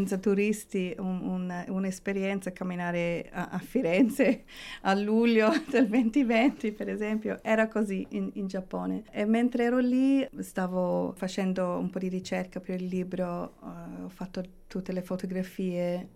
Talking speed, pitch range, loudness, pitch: 140 wpm, 185-220 Hz, -29 LUFS, 195 Hz